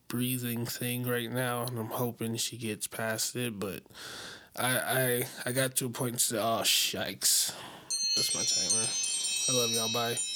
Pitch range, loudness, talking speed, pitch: 115-125 Hz, -29 LUFS, 175 wpm, 120 Hz